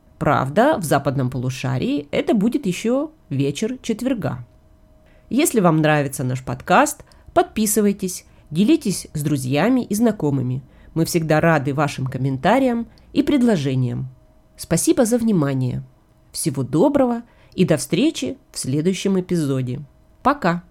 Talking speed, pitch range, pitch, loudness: 115 wpm, 135-230 Hz, 165 Hz, -20 LUFS